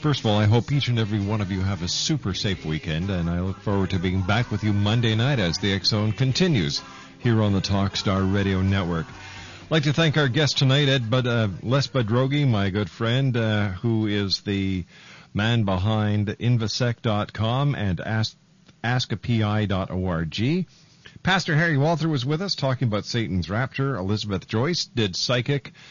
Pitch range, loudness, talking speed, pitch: 100-135 Hz, -23 LUFS, 180 wpm, 110 Hz